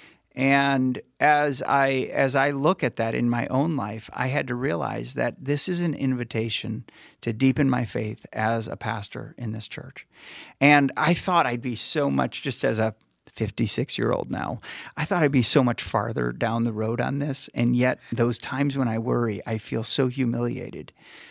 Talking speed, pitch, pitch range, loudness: 190 wpm, 125 Hz, 115-140 Hz, -24 LUFS